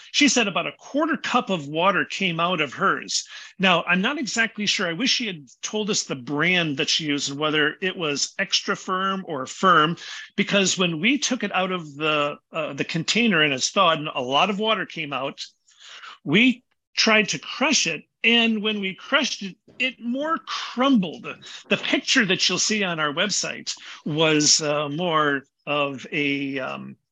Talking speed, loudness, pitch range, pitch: 185 wpm, -22 LUFS, 150-220 Hz, 185 Hz